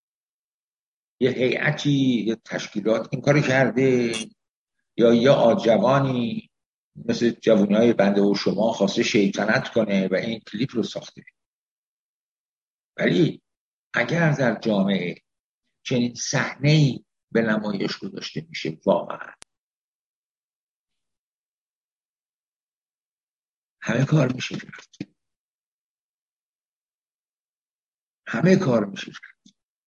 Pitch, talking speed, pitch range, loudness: 120 Hz, 85 wpm, 110-130 Hz, -22 LUFS